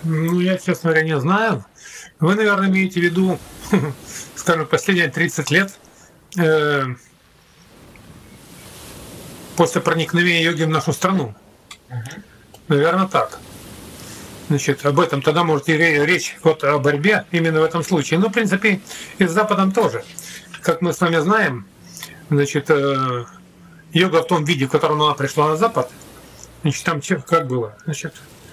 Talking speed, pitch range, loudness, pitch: 140 wpm, 150-180 Hz, -18 LUFS, 165 Hz